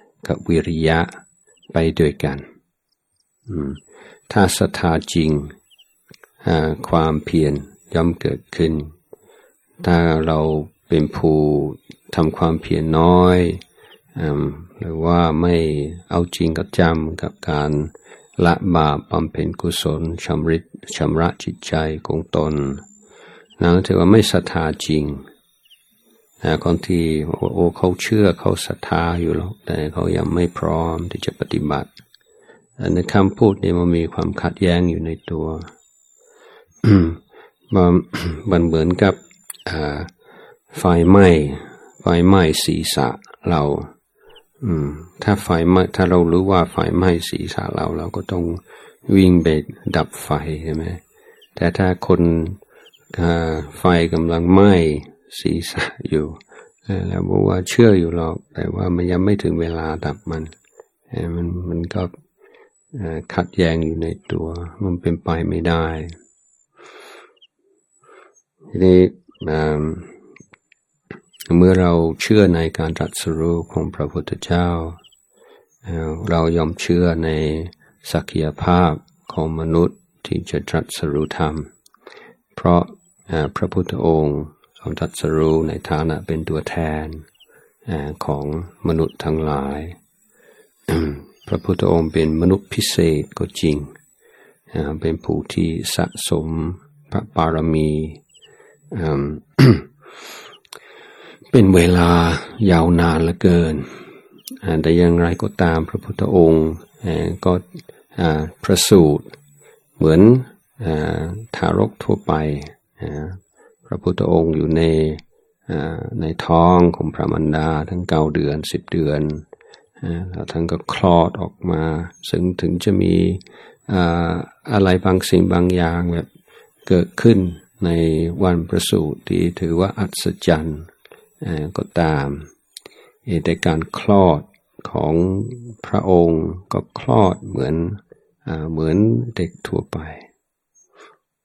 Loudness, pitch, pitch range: -18 LUFS, 85 Hz, 80-90 Hz